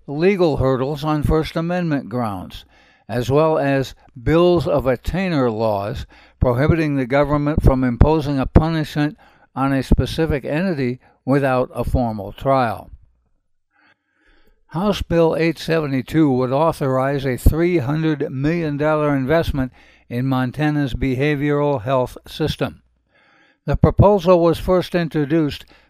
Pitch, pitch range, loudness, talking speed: 145 Hz, 130-160 Hz, -19 LUFS, 110 wpm